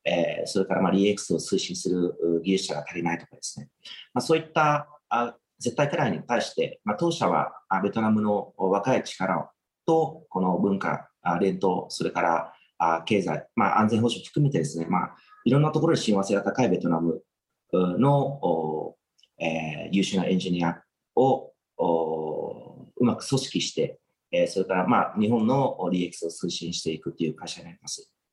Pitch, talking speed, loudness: 100 Hz, 315 characters per minute, -26 LUFS